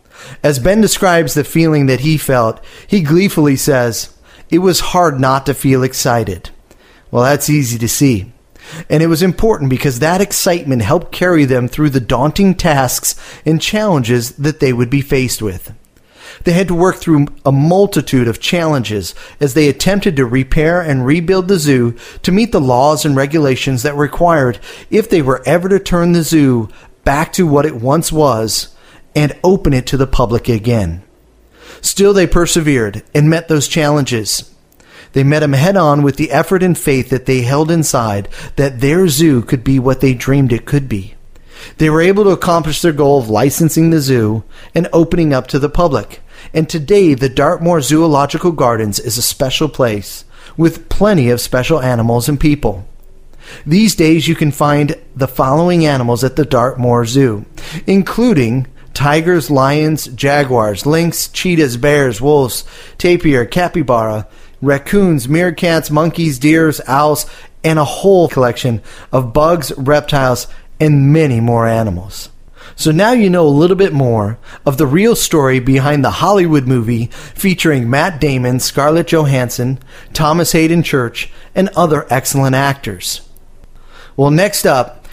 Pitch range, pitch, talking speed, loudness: 125-165 Hz, 145 Hz, 160 wpm, -12 LUFS